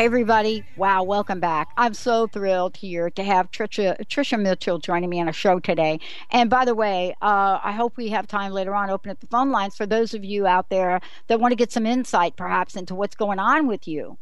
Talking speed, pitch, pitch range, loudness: 230 wpm, 200 Hz, 185-230 Hz, -22 LUFS